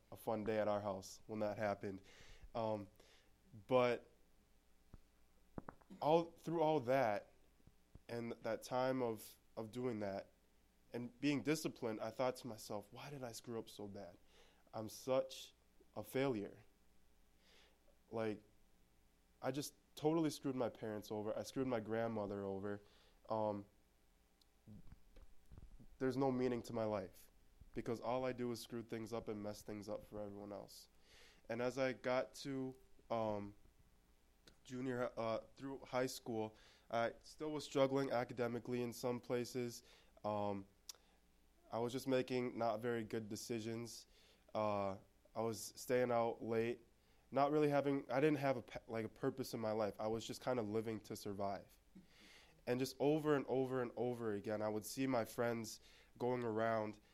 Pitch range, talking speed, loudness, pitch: 105-125 Hz, 150 wpm, -43 LUFS, 115 Hz